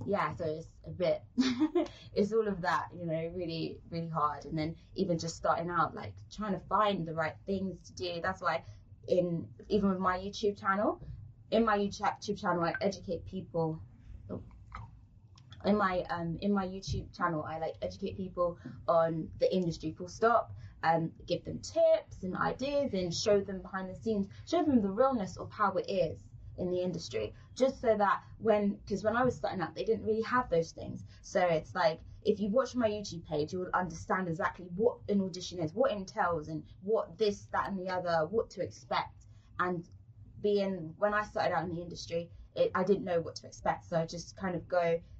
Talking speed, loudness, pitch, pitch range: 200 wpm, -33 LUFS, 180 Hz, 160-205 Hz